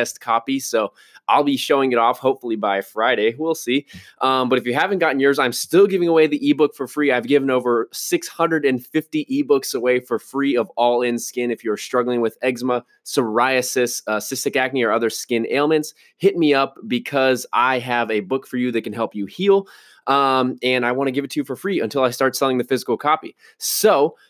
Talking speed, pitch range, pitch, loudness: 215 wpm, 120-155 Hz, 130 Hz, -19 LUFS